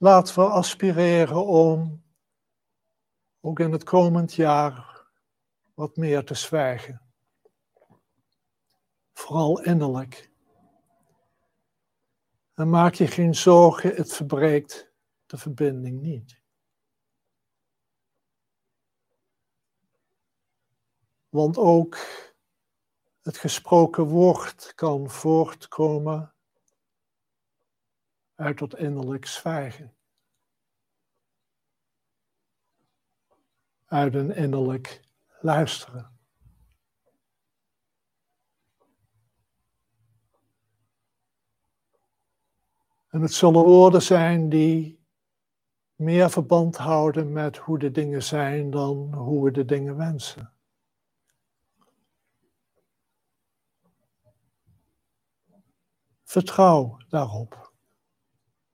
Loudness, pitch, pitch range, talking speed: -21 LUFS, 150 Hz, 130-165 Hz, 65 wpm